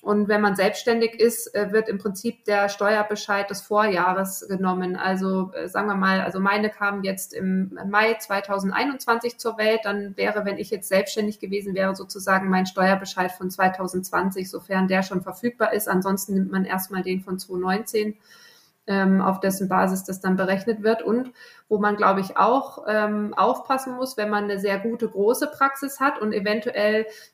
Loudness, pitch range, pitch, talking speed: -23 LUFS, 190-215 Hz, 200 Hz, 165 wpm